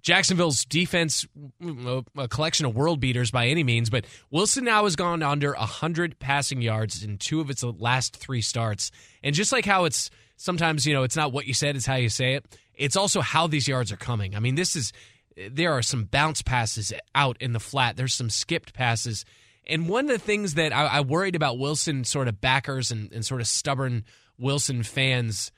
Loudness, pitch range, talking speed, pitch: -25 LUFS, 115-155 Hz, 210 wpm, 130 Hz